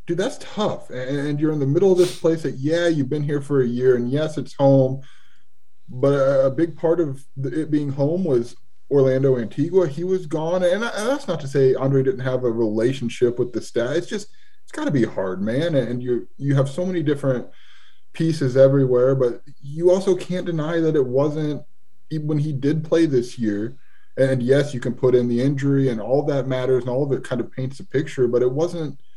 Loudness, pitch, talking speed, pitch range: -21 LUFS, 140 Hz, 220 wpm, 130-155 Hz